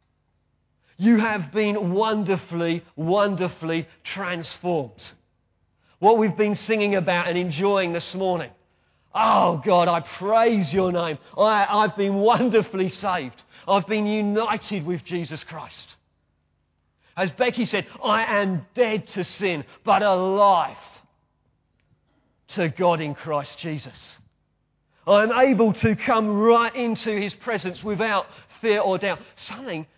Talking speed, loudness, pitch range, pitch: 120 wpm, -22 LUFS, 160-210 Hz, 185 Hz